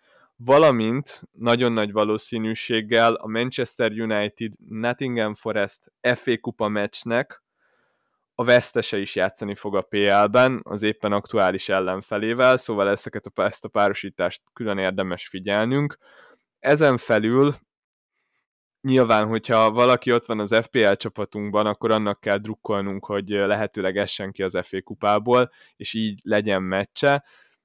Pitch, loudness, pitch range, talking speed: 110 Hz, -22 LUFS, 100-120 Hz, 125 wpm